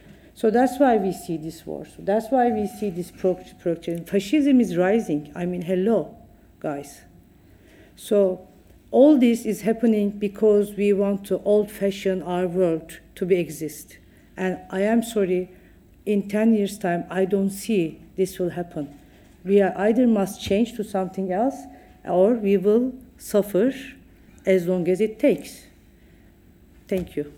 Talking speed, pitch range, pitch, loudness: 155 wpm, 180-215 Hz, 195 Hz, -22 LUFS